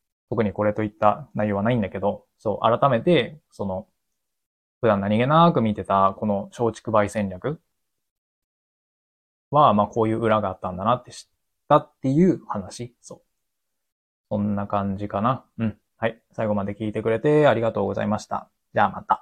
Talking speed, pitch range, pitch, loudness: 325 characters per minute, 100-115 Hz, 105 Hz, -23 LUFS